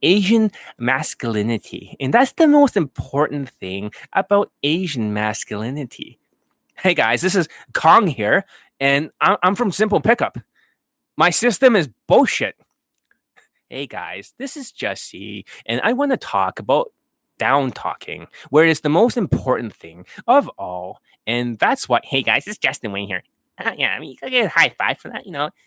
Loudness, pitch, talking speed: -18 LUFS, 150 Hz, 160 wpm